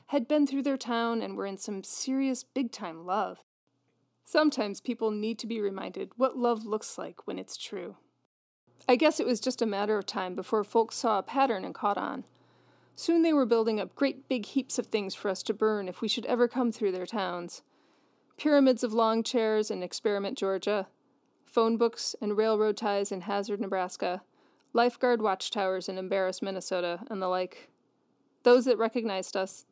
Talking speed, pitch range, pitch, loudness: 185 wpm, 195-245 Hz, 220 Hz, -29 LUFS